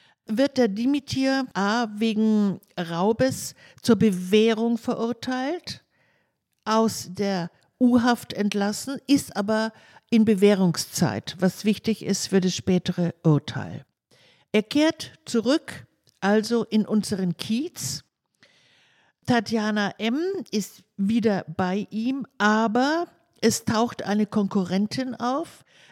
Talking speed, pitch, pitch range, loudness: 100 wpm, 215 Hz, 195-240 Hz, -24 LUFS